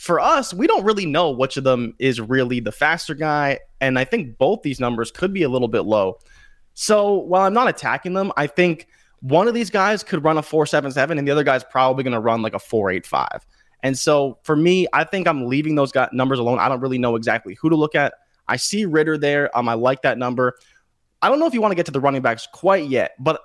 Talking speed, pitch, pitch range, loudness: 250 wpm, 145 Hz, 130-175 Hz, -19 LUFS